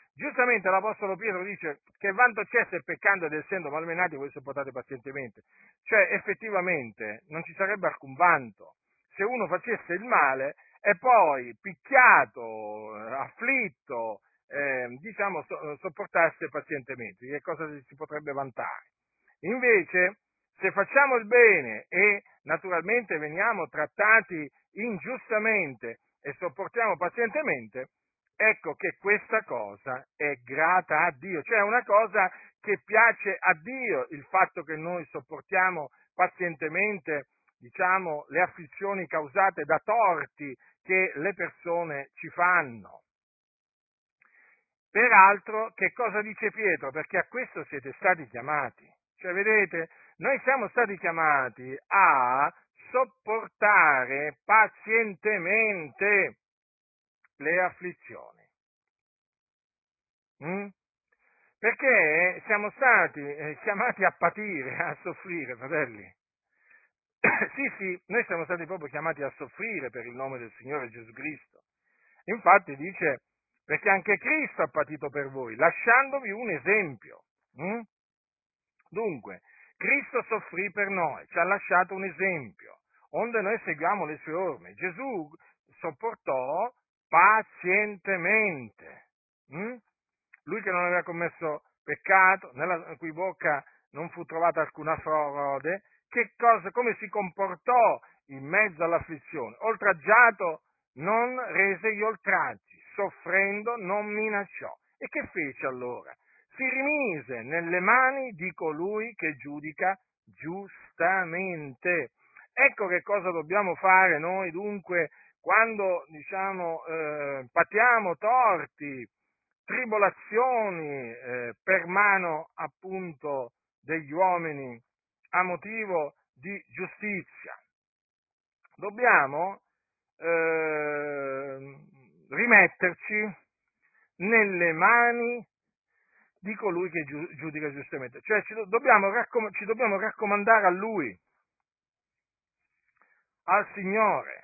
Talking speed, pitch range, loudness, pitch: 105 wpm, 155-210 Hz, -26 LUFS, 185 Hz